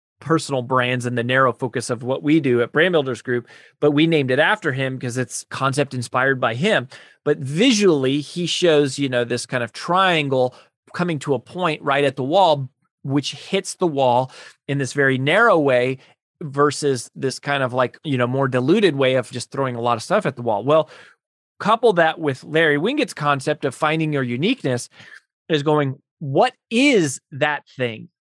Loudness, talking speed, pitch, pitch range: -20 LUFS, 190 wpm, 140 Hz, 130-155 Hz